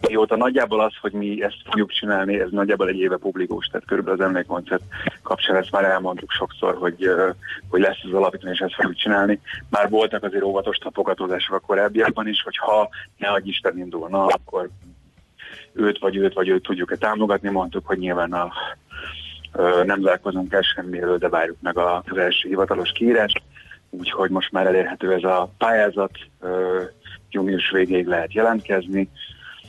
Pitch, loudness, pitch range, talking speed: 95 Hz, -21 LUFS, 90-100 Hz, 165 wpm